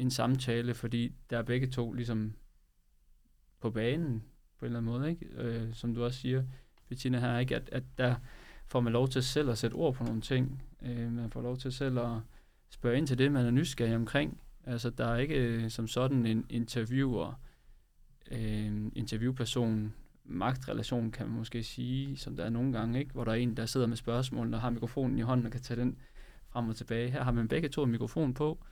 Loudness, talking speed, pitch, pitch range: -34 LUFS, 210 wpm, 120 Hz, 115-130 Hz